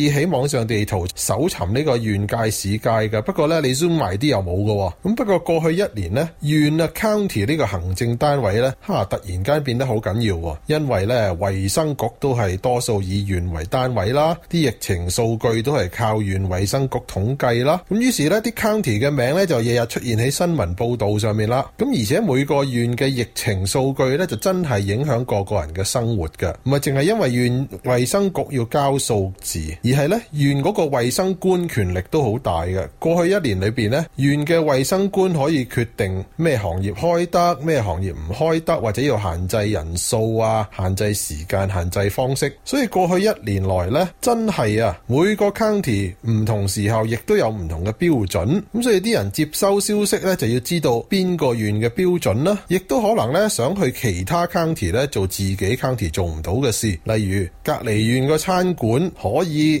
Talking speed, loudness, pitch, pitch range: 310 characters per minute, -20 LUFS, 125 Hz, 105-160 Hz